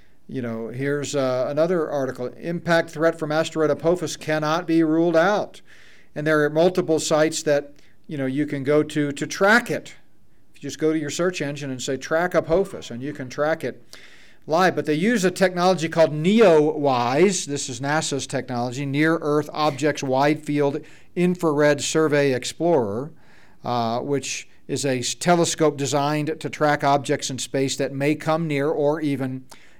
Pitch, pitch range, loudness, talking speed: 150 Hz, 140-160 Hz, -22 LUFS, 170 wpm